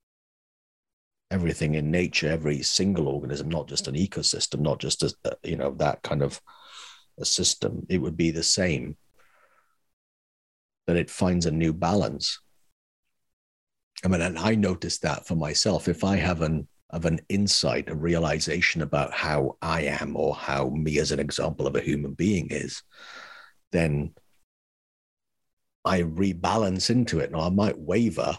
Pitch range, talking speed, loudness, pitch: 75-95 Hz, 150 wpm, -26 LUFS, 85 Hz